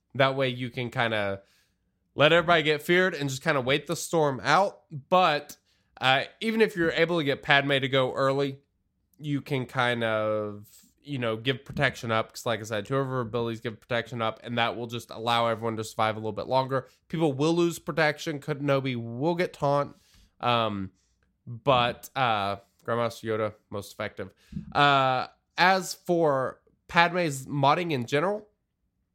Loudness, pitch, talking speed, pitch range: -26 LUFS, 135 Hz, 175 wpm, 115-150 Hz